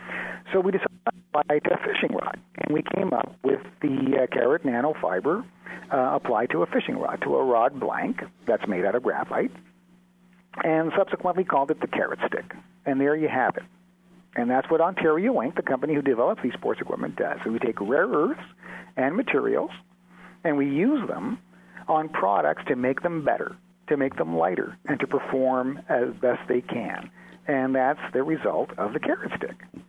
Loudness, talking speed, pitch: -25 LUFS, 190 wpm, 135 Hz